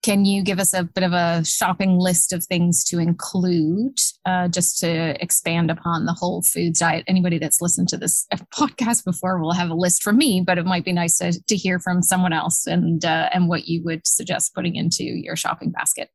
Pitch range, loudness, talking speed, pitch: 170-185 Hz, -20 LUFS, 220 wpm, 180 Hz